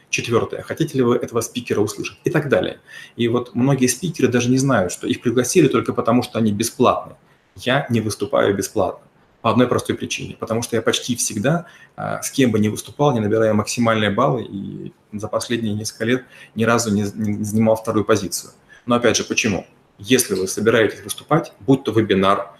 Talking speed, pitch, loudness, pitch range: 185 wpm, 115 Hz, -19 LUFS, 110-125 Hz